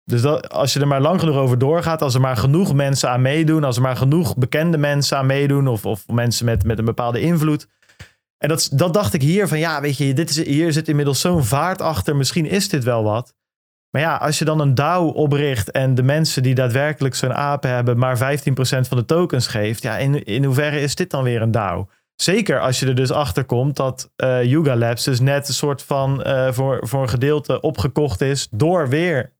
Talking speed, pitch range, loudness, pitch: 230 wpm, 130-150 Hz, -18 LUFS, 140 Hz